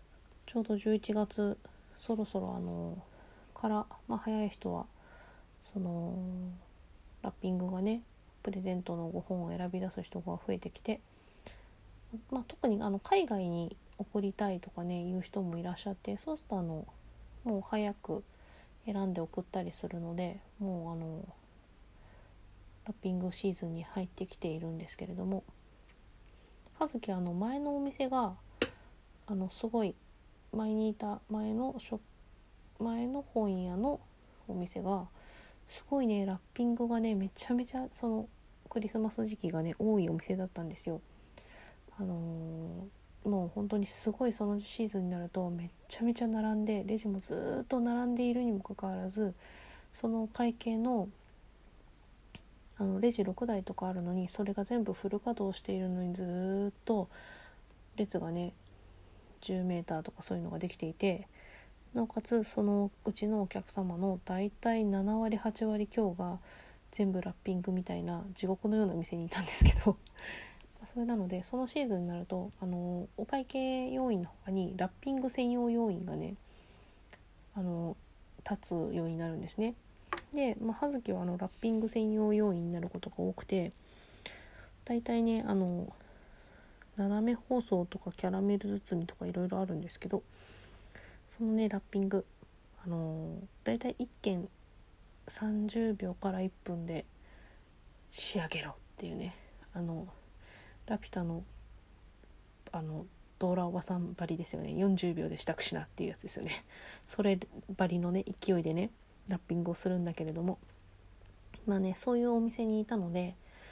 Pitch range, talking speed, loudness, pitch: 175-215 Hz, 285 characters per minute, -36 LUFS, 195 Hz